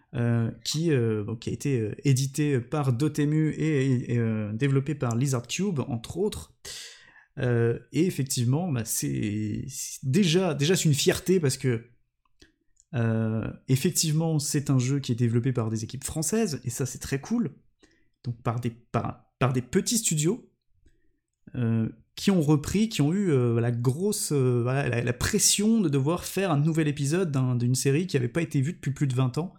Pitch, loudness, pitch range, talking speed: 135 Hz, -26 LUFS, 120-160 Hz, 185 wpm